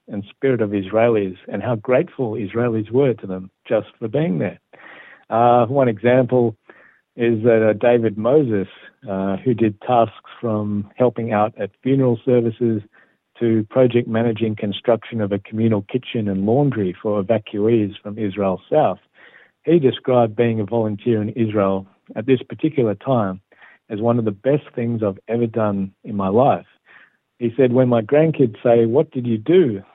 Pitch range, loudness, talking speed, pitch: 105-125 Hz, -19 LUFS, 160 wpm, 115 Hz